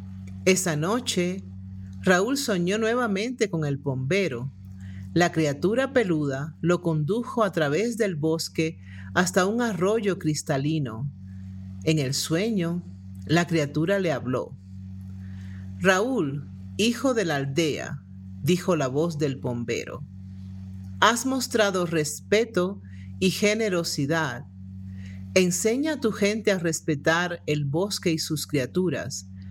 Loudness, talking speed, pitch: -25 LUFS, 110 wpm, 160 Hz